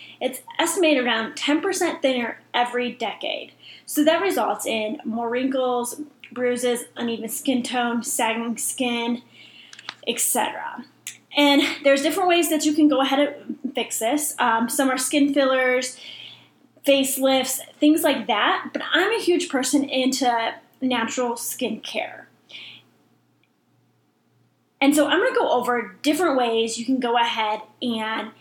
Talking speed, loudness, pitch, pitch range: 135 wpm, -22 LUFS, 260 Hz, 240-295 Hz